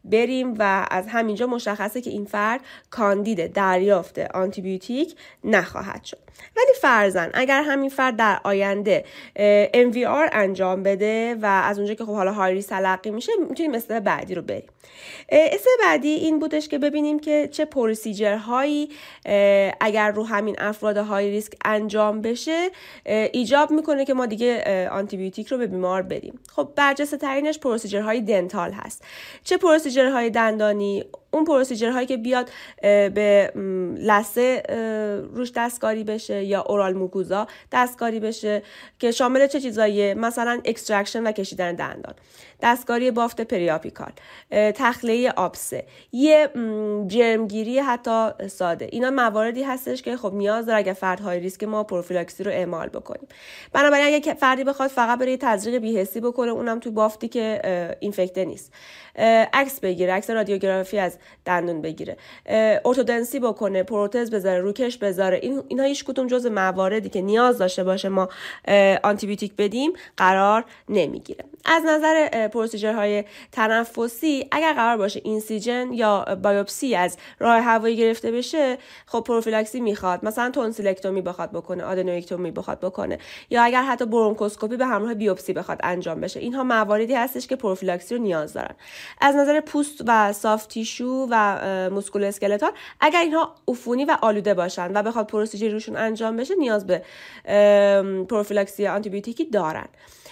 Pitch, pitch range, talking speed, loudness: 220 Hz, 200-255 Hz, 145 wpm, -22 LUFS